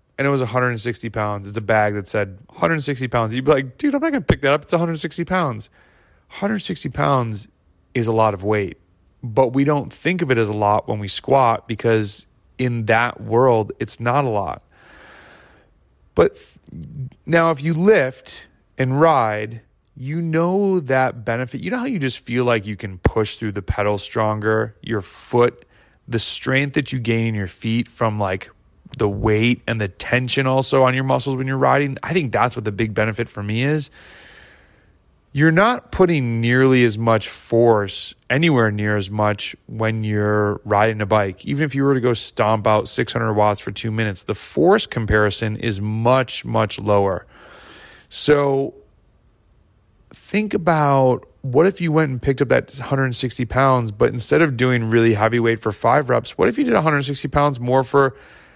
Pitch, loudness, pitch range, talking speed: 120 Hz, -19 LUFS, 105-135 Hz, 185 wpm